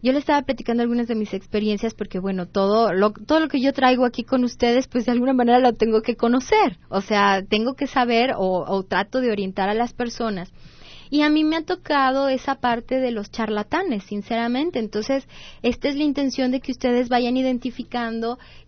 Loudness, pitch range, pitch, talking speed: -21 LUFS, 215-260 Hz, 245 Hz, 200 wpm